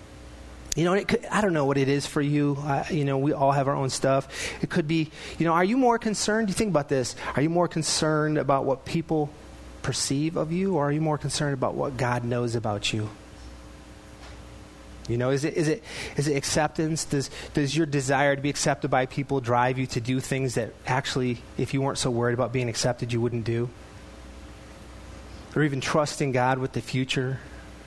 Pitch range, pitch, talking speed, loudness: 120-155 Hz, 140 Hz, 210 wpm, -26 LUFS